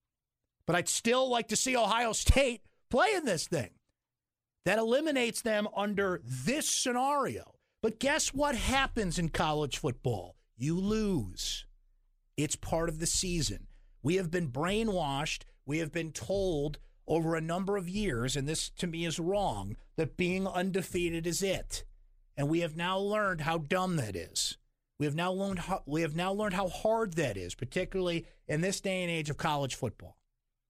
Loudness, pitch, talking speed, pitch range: -32 LUFS, 175 Hz, 160 wpm, 145-200 Hz